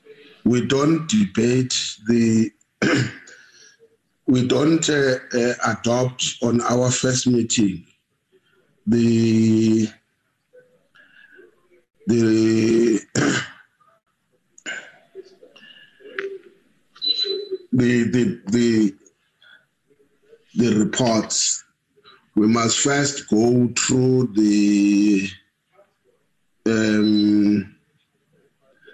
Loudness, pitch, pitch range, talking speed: -19 LUFS, 120 Hz, 110-155 Hz, 60 wpm